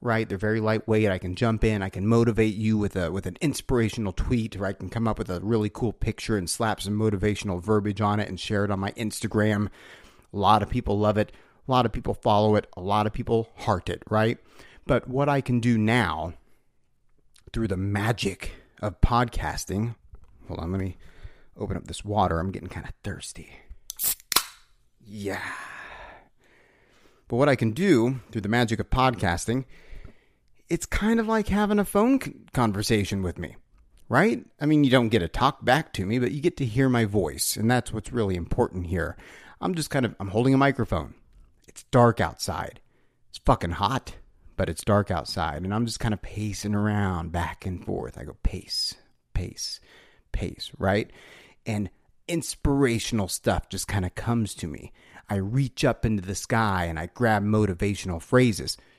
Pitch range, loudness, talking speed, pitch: 95-120 Hz, -26 LUFS, 185 wpm, 105 Hz